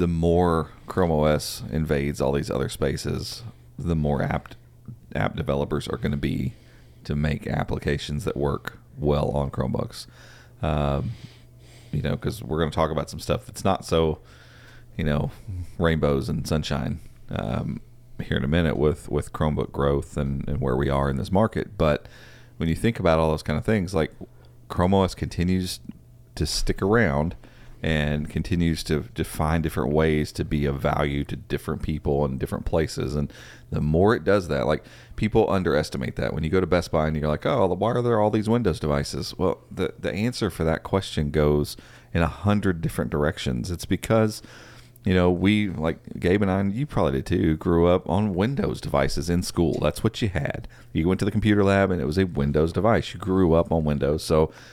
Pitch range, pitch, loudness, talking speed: 75-100 Hz, 80 Hz, -25 LUFS, 195 wpm